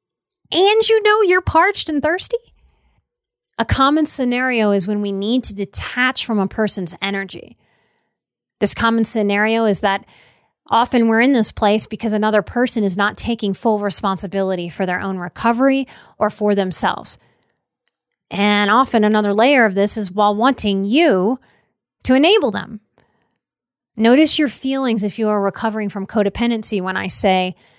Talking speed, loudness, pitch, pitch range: 150 wpm, -17 LUFS, 215 Hz, 200-255 Hz